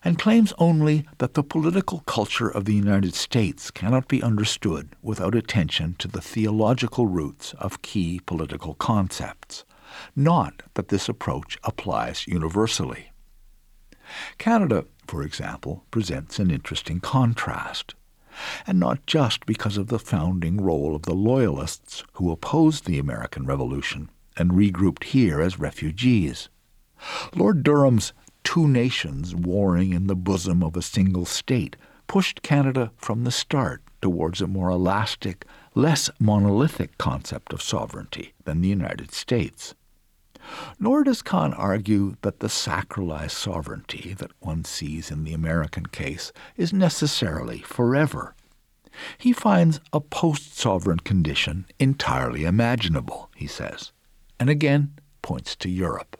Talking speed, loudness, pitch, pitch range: 130 wpm, -24 LUFS, 105 Hz, 90-135 Hz